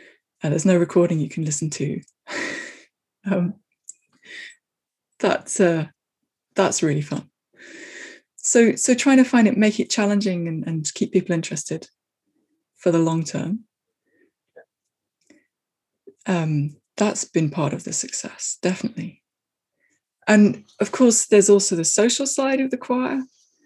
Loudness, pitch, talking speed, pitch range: -21 LUFS, 205 Hz, 130 wpm, 165-250 Hz